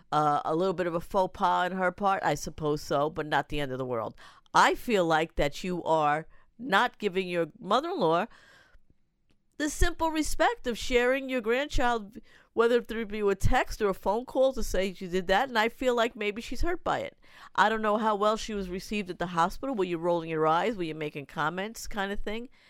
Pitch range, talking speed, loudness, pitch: 170-230 Hz, 225 wpm, -28 LUFS, 195 Hz